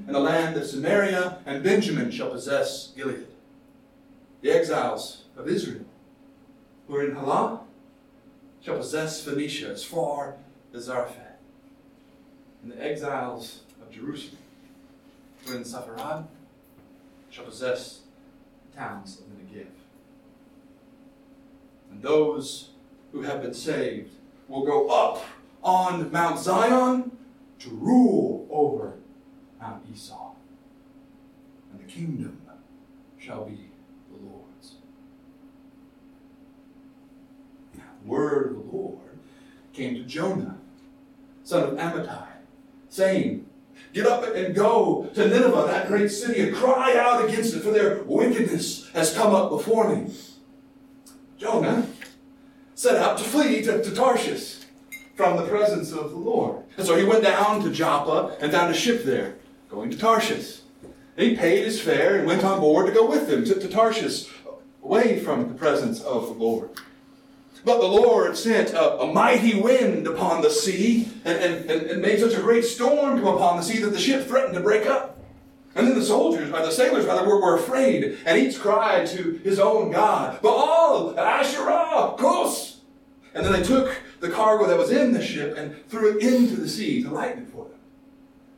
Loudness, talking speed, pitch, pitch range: -22 LUFS, 150 wpm, 250 Hz, 195-270 Hz